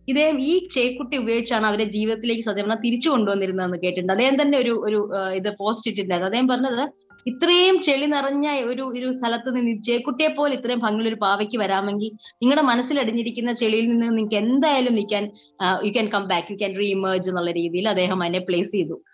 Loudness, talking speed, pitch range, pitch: -22 LUFS, 170 wpm, 200-255 Hz, 225 Hz